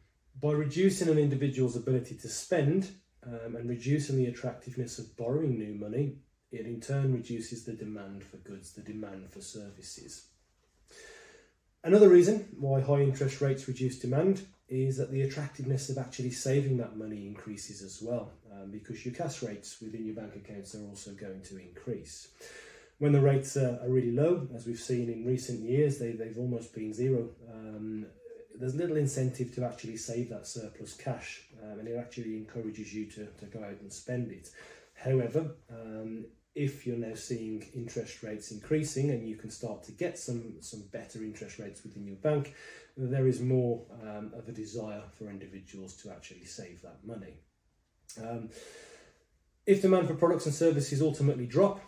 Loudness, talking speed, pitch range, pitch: -32 LUFS, 170 wpm, 110-140 Hz, 120 Hz